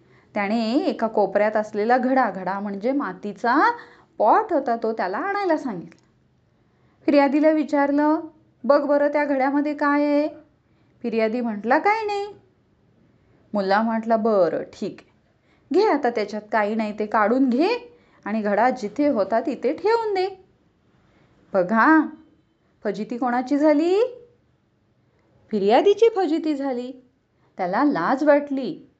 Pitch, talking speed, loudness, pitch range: 275 Hz, 115 wpm, -21 LUFS, 225-310 Hz